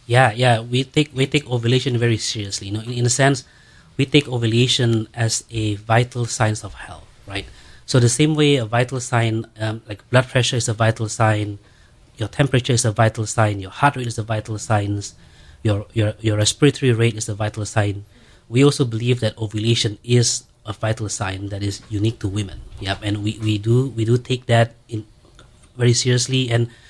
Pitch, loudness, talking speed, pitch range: 115 Hz, -20 LUFS, 200 wpm, 105-125 Hz